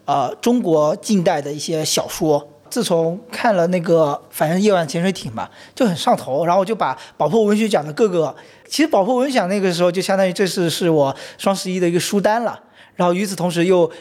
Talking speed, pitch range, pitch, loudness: 330 characters per minute, 165-205 Hz, 180 Hz, -18 LUFS